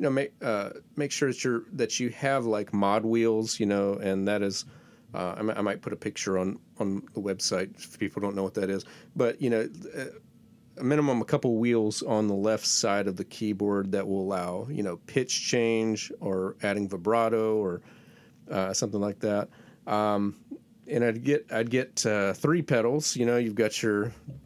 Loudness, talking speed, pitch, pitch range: -28 LUFS, 200 wpm, 110 Hz, 100-120 Hz